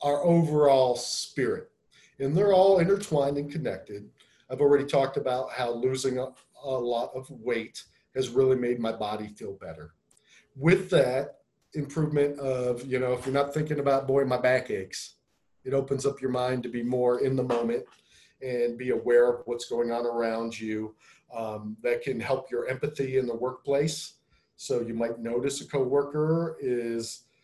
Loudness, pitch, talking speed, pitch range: -27 LUFS, 130 Hz, 170 wpm, 120-140 Hz